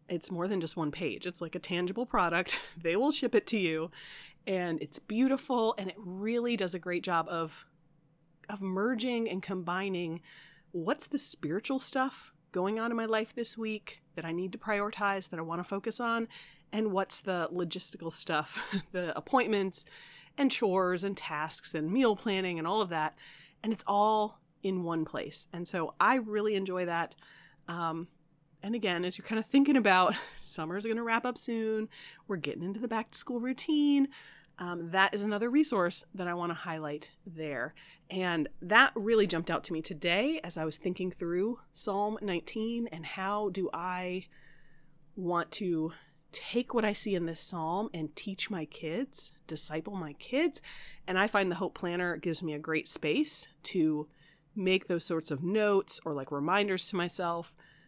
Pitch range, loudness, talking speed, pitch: 165-215 Hz, -32 LUFS, 180 wpm, 185 Hz